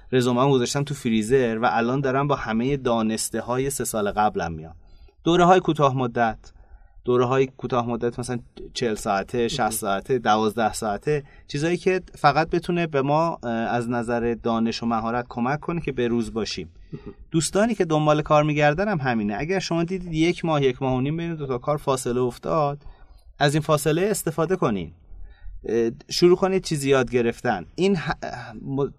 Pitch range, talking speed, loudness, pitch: 115-155 Hz, 170 wpm, -23 LUFS, 130 Hz